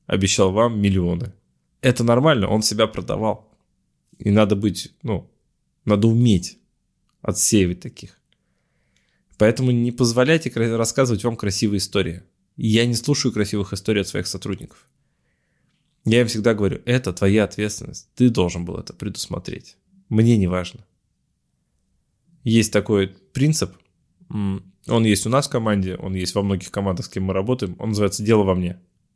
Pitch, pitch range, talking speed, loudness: 105 Hz, 95-120 Hz, 140 wpm, -20 LUFS